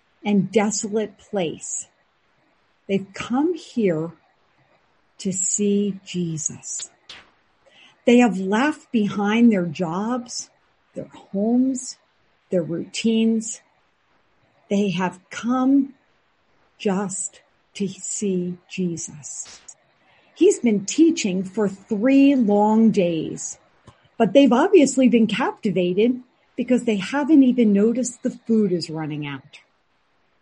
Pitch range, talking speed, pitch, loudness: 190-250 Hz, 95 wpm, 215 Hz, -21 LUFS